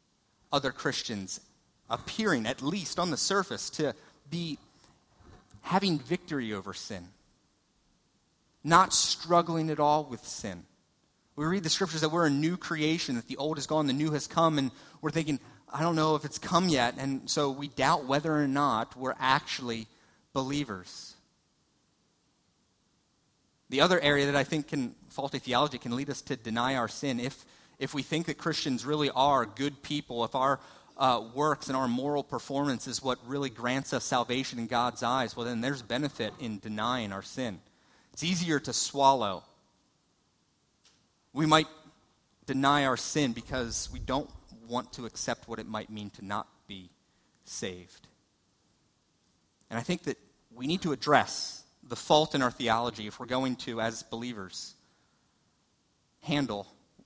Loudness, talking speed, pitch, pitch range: -30 LUFS, 160 wpm, 135 Hz, 115-150 Hz